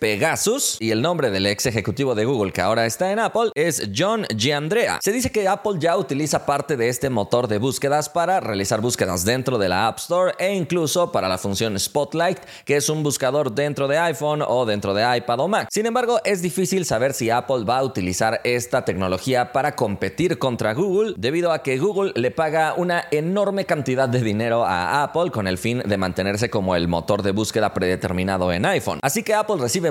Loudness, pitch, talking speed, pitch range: -21 LUFS, 135 Hz, 205 wpm, 110-170 Hz